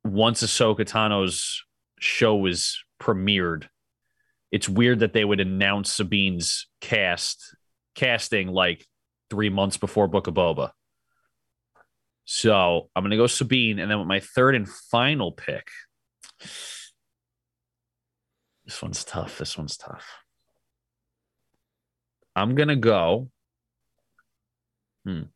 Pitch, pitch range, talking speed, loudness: 100 Hz, 85-110 Hz, 105 wpm, -23 LUFS